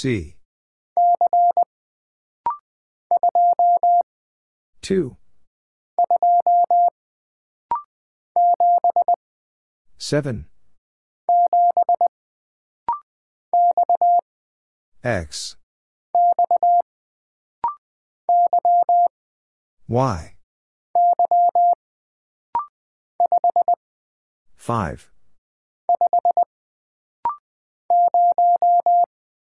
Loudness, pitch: -19 LUFS, 350 Hz